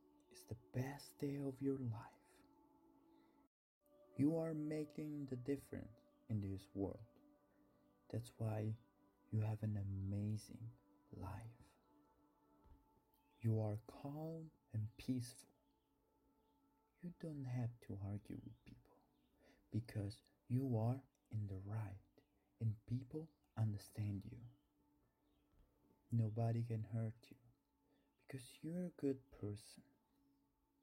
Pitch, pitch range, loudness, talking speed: 120 Hz, 105-145 Hz, -47 LUFS, 105 wpm